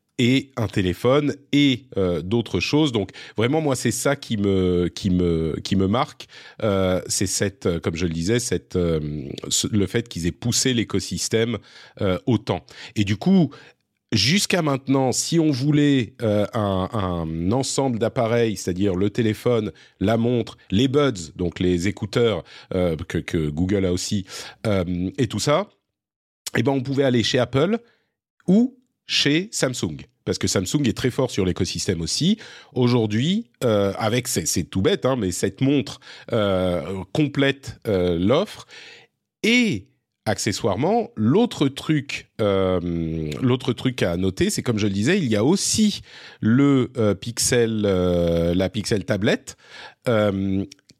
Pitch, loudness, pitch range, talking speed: 110 Hz, -22 LUFS, 95-130 Hz, 145 wpm